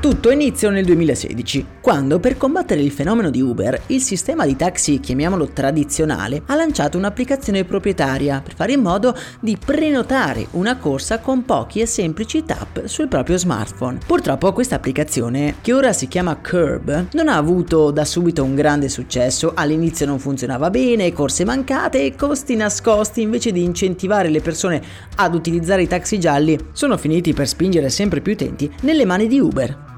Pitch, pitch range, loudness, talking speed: 175 Hz, 145-235 Hz, -18 LUFS, 165 wpm